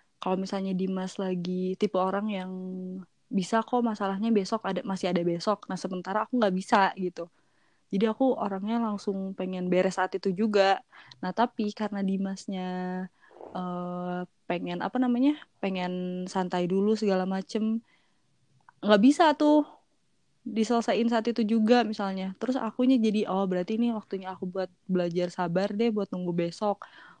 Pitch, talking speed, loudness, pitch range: 195 Hz, 145 wpm, -28 LUFS, 185-220 Hz